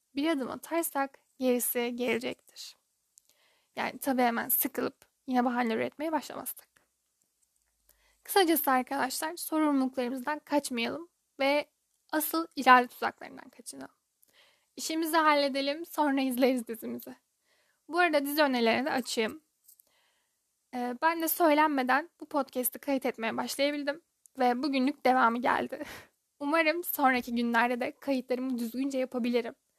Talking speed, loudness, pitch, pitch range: 105 wpm, -29 LUFS, 275 Hz, 250-300 Hz